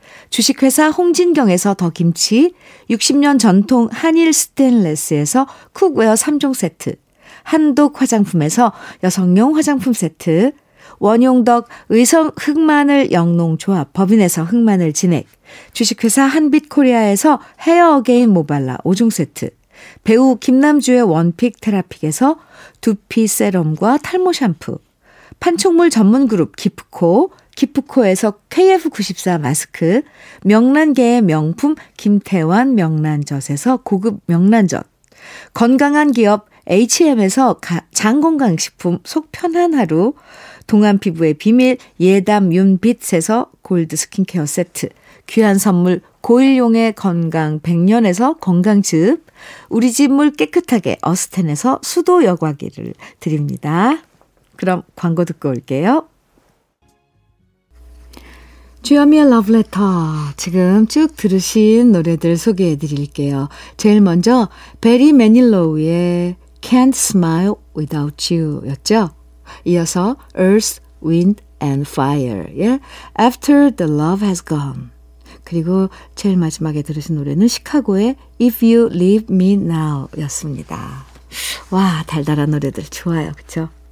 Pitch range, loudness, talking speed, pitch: 165-255 Hz, -14 LUFS, 275 characters per minute, 205 Hz